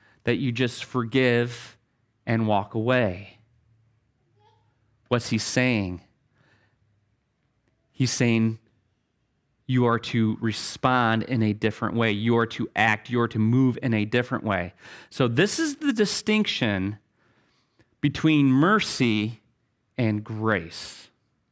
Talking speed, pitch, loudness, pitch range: 115 wpm, 115 Hz, -24 LUFS, 110-125 Hz